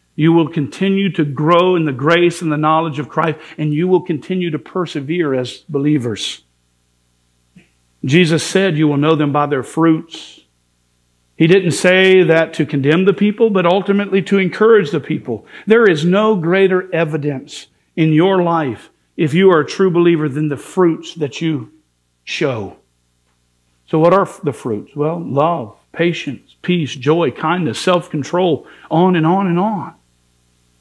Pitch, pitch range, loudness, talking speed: 160 Hz, 140-180 Hz, -15 LUFS, 160 wpm